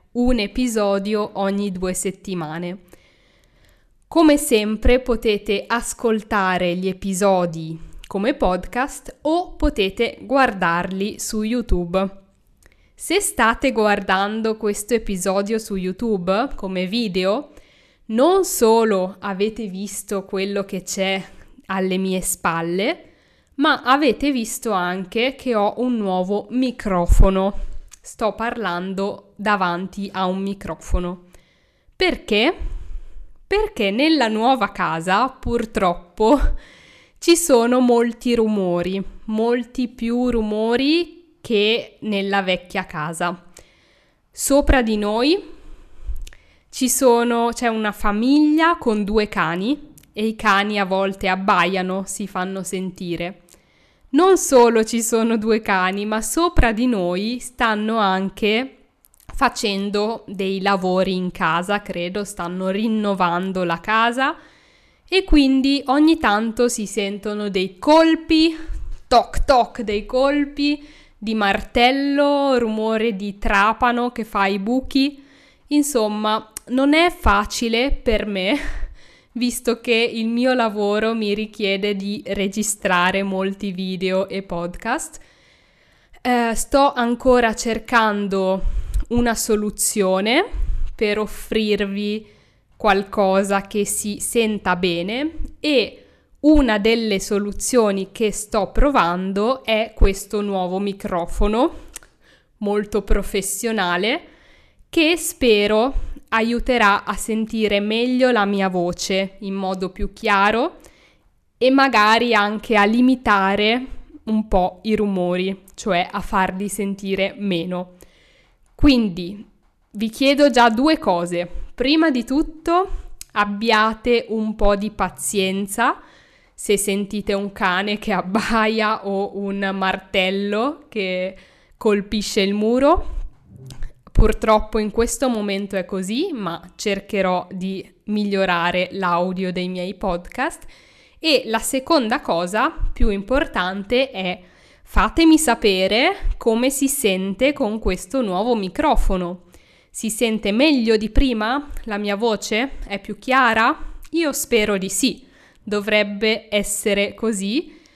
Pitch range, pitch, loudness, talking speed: 195-245 Hz, 215 Hz, -20 LUFS, 105 wpm